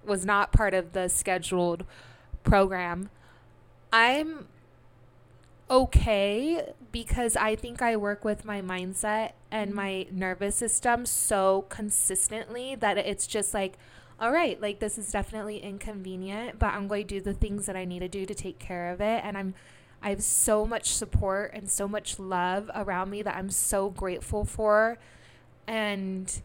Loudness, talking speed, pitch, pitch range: -28 LUFS, 160 wpm, 200 Hz, 185-215 Hz